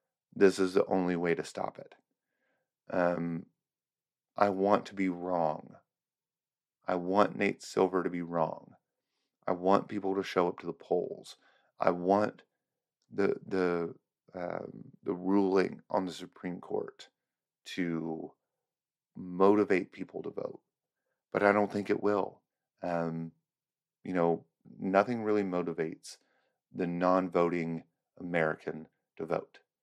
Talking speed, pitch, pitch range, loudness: 125 wpm, 90 Hz, 85-100 Hz, -32 LUFS